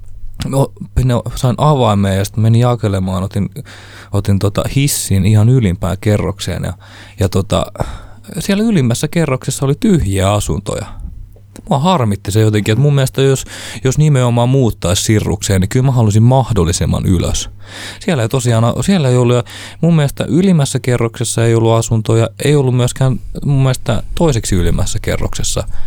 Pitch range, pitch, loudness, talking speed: 100-130 Hz, 110 Hz, -14 LUFS, 140 wpm